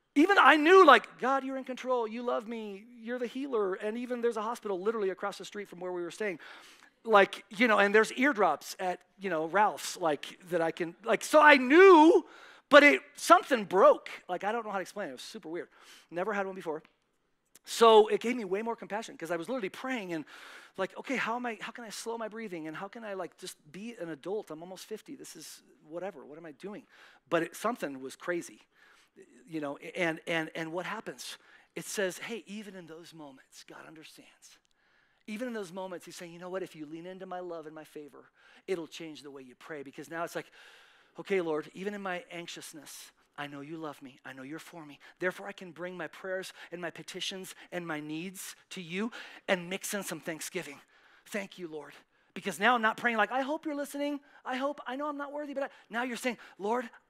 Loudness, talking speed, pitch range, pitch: -29 LUFS, 230 wpm, 170-235 Hz, 195 Hz